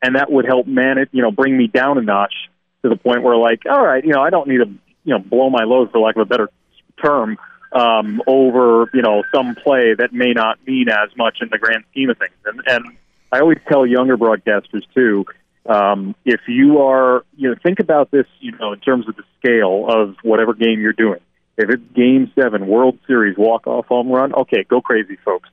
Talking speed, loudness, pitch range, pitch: 230 wpm, -15 LUFS, 110-130 Hz, 125 Hz